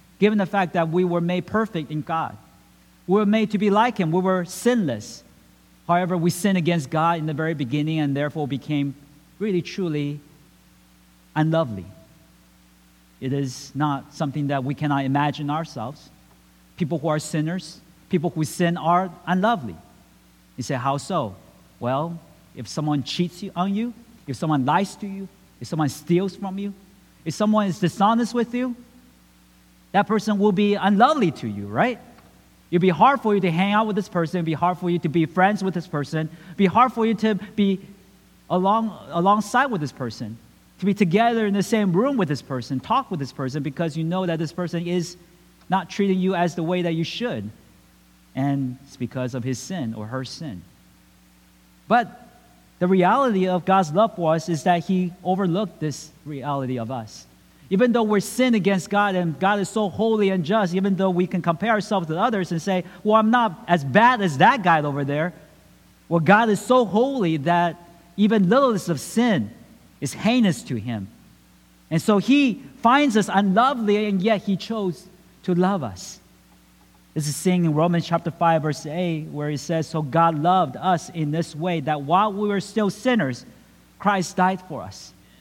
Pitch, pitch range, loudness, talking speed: 175 Hz, 145-200 Hz, -22 LUFS, 185 wpm